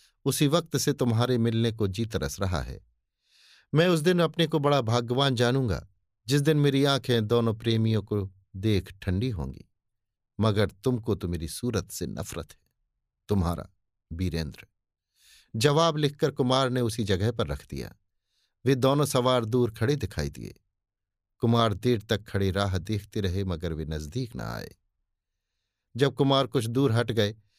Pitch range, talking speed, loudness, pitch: 95-130 Hz, 155 wpm, -27 LUFS, 110 Hz